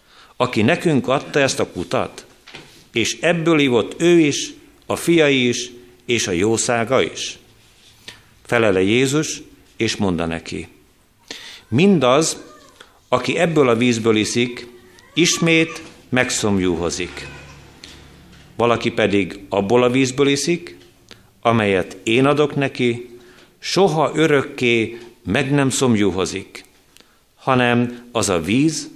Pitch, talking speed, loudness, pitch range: 120 Hz, 105 wpm, -18 LUFS, 110-145 Hz